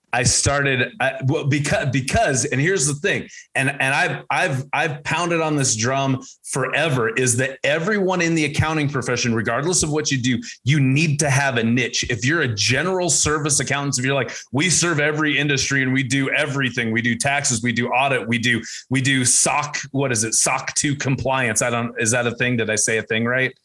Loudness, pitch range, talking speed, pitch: -19 LUFS, 125-150 Hz, 215 wpm, 135 Hz